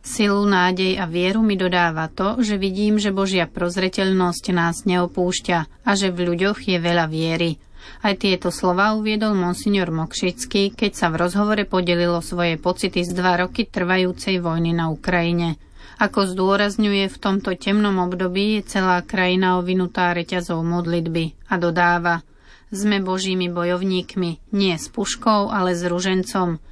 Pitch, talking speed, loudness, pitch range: 185 Hz, 145 wpm, -20 LUFS, 175-200 Hz